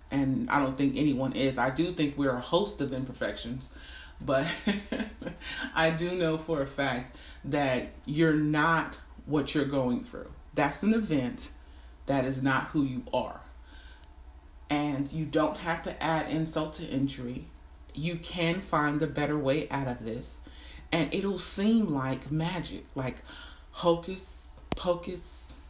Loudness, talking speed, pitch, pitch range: -30 LUFS, 145 wpm, 145 Hz, 130-165 Hz